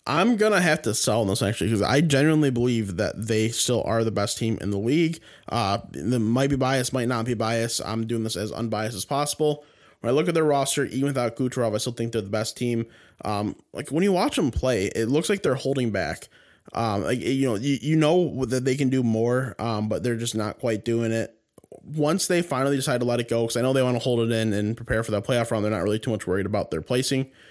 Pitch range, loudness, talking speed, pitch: 110-135 Hz, -24 LUFS, 255 wpm, 120 Hz